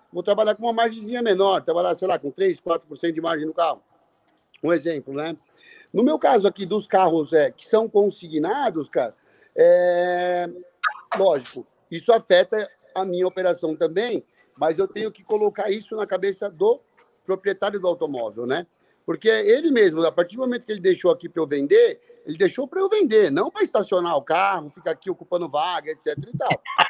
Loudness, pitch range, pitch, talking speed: -22 LUFS, 175-250 Hz, 195 Hz, 185 wpm